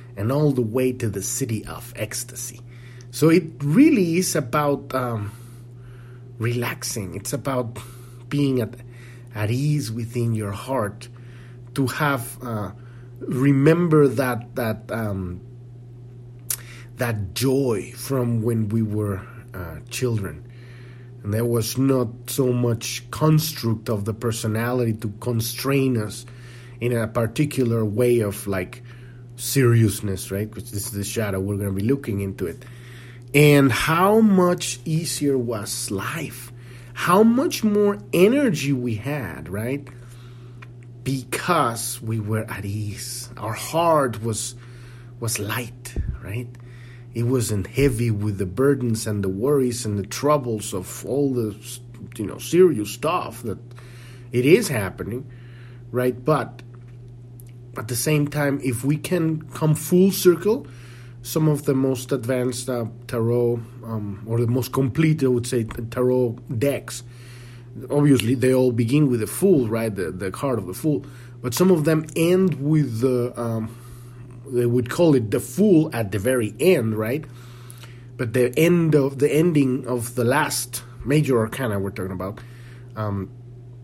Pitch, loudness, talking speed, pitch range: 120 Hz, -22 LUFS, 140 wpm, 115-135 Hz